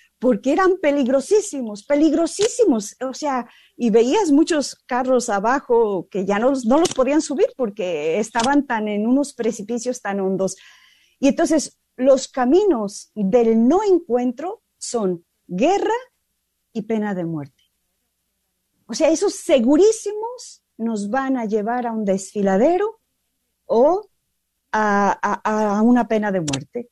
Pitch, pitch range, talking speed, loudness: 255 Hz, 220-325 Hz, 130 wpm, -19 LUFS